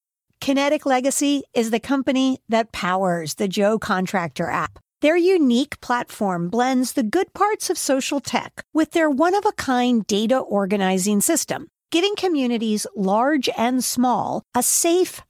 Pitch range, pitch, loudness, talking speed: 210-300 Hz, 255 Hz, -21 LUFS, 145 wpm